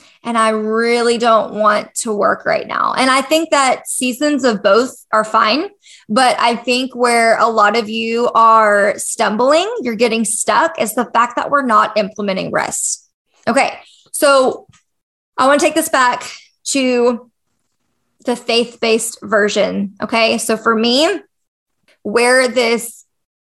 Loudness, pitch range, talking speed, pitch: -14 LUFS, 220-260 Hz, 150 wpm, 235 Hz